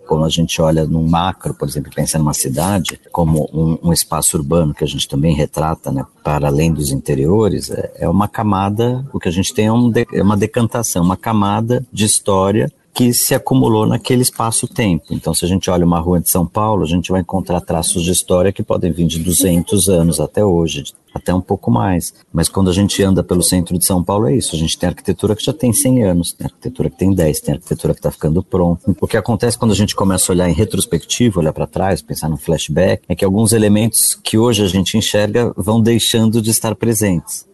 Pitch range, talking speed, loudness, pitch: 85-110 Hz, 225 wpm, -15 LUFS, 95 Hz